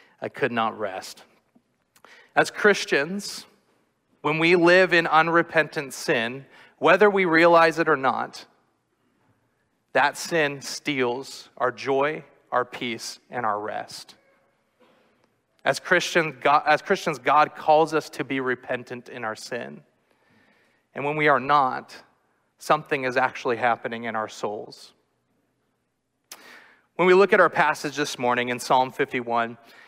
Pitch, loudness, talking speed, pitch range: 150 Hz, -22 LUFS, 125 wpm, 125-165 Hz